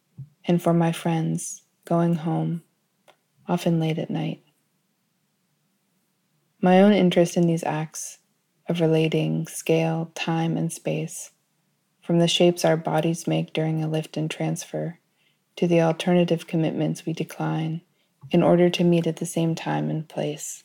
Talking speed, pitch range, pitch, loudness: 140 wpm, 160-175 Hz, 165 Hz, -23 LUFS